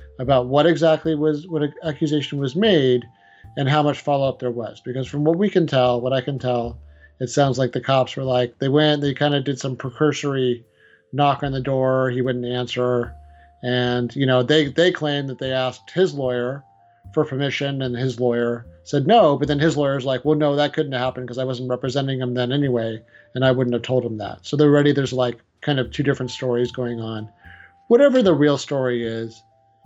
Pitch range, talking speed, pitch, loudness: 125-145 Hz, 215 wpm, 130 Hz, -20 LUFS